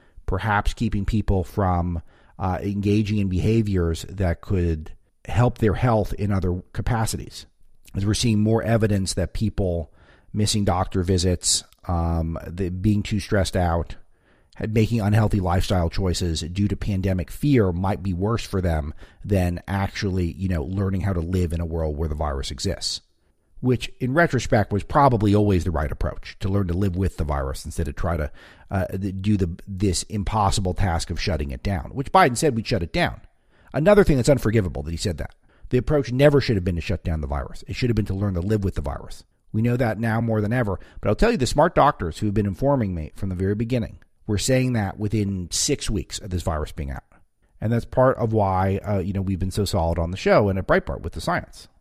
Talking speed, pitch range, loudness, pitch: 210 wpm, 85-110 Hz, -23 LUFS, 95 Hz